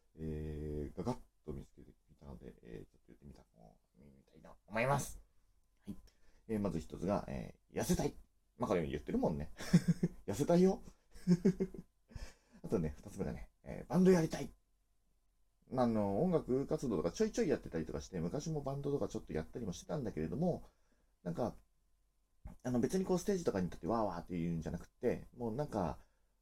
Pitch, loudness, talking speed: 95 Hz, -38 LUFS, 350 characters per minute